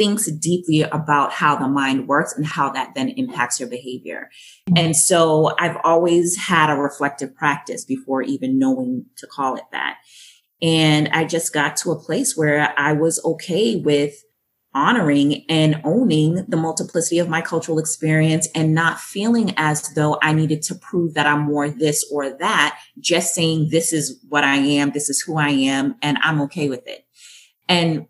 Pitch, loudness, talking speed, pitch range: 155 Hz, -19 LUFS, 175 wpm, 145-165 Hz